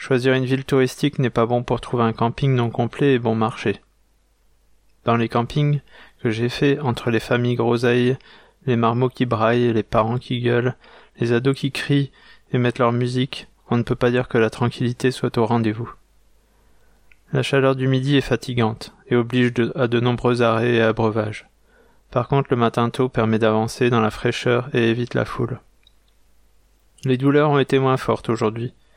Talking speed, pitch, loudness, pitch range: 180 wpm, 120 Hz, -20 LUFS, 115-130 Hz